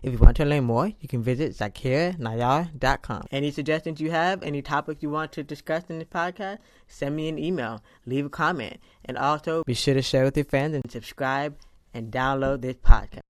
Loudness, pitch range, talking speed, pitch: -26 LUFS, 130-155 Hz, 205 wpm, 140 Hz